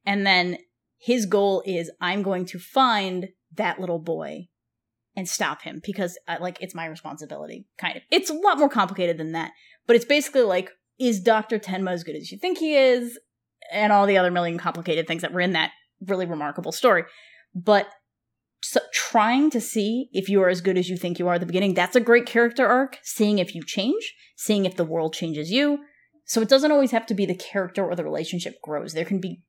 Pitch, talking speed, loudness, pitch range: 190 Hz, 220 wpm, -23 LUFS, 175-235 Hz